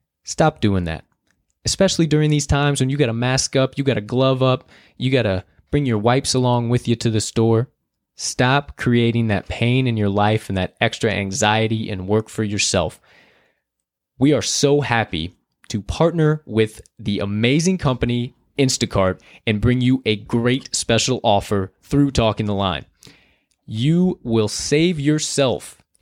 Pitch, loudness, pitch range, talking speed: 120 Hz, -19 LUFS, 105-135 Hz, 165 wpm